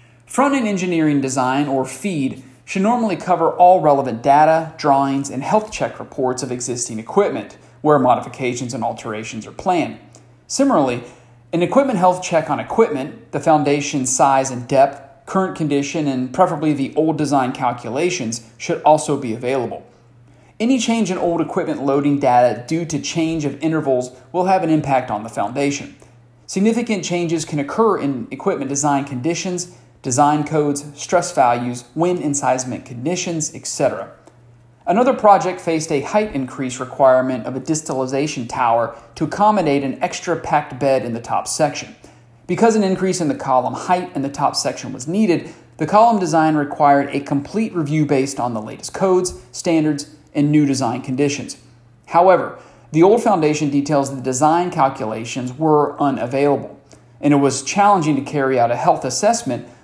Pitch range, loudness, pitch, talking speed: 130-165 Hz, -18 LUFS, 145 Hz, 155 wpm